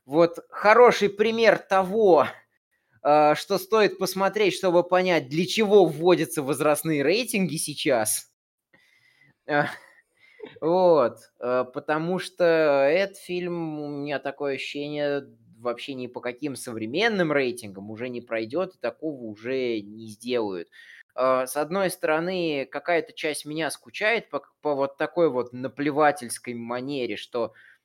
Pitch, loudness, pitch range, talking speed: 155 Hz, -24 LUFS, 135-185 Hz, 125 wpm